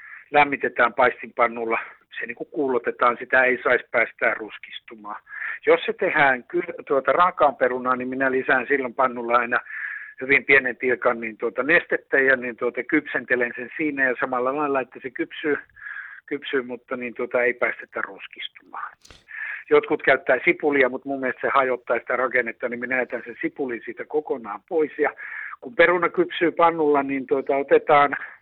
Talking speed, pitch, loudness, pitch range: 155 wpm, 135 Hz, -22 LUFS, 125-155 Hz